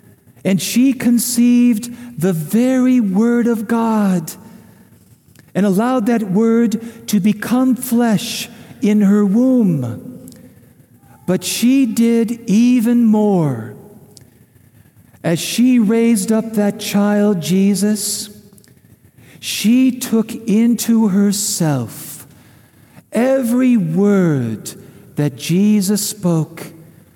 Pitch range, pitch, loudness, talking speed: 170-230 Hz, 210 Hz, -15 LUFS, 85 wpm